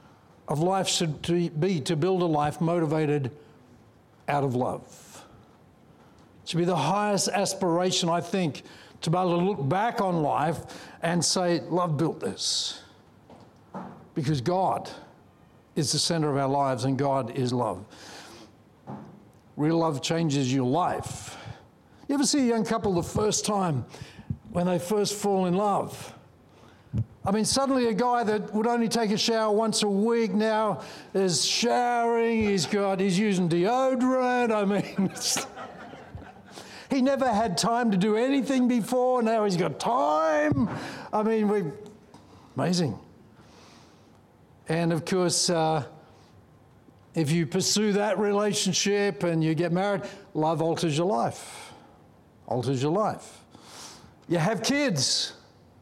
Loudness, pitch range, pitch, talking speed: -26 LUFS, 160-215 Hz, 185 Hz, 135 wpm